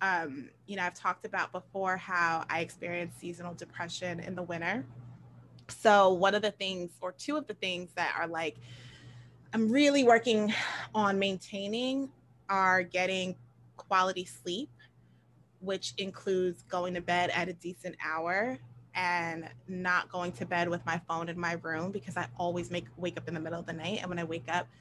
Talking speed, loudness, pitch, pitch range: 180 wpm, -32 LUFS, 175 Hz, 165-190 Hz